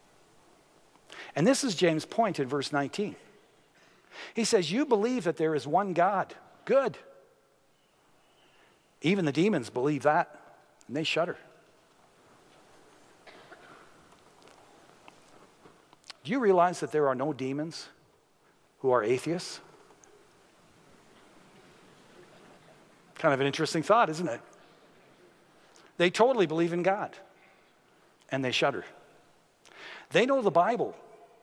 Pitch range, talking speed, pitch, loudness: 150-225 Hz, 105 wpm, 175 Hz, -28 LUFS